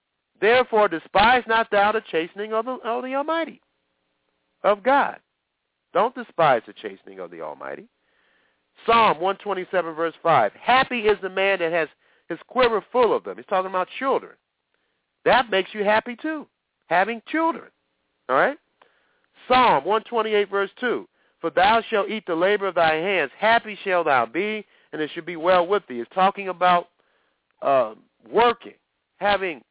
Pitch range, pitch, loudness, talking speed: 175-230 Hz, 205 Hz, -22 LUFS, 160 wpm